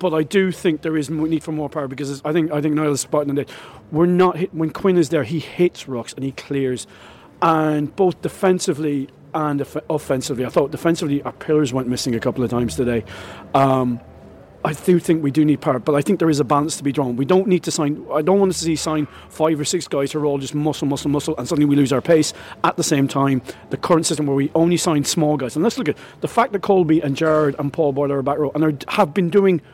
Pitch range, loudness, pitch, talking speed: 140-165 Hz, -19 LUFS, 150 Hz, 260 wpm